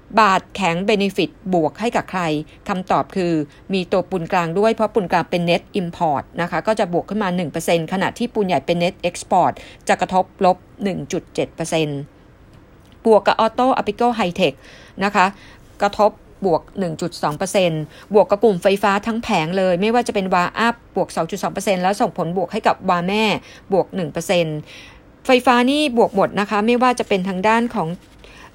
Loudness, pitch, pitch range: -19 LUFS, 190 Hz, 175-215 Hz